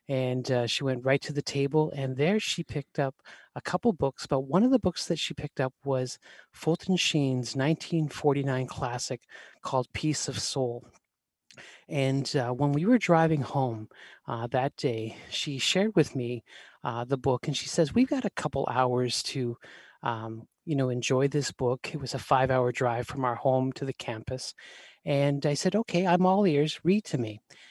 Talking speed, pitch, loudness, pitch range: 190 wpm, 140 Hz, -28 LUFS, 130-155 Hz